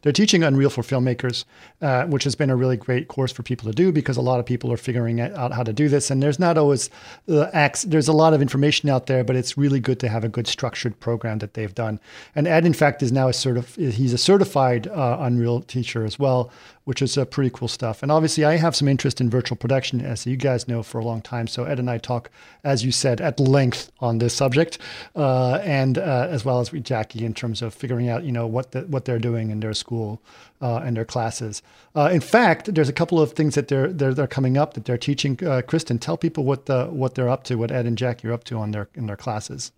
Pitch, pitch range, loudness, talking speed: 130 Hz, 120-145 Hz, -22 LUFS, 260 wpm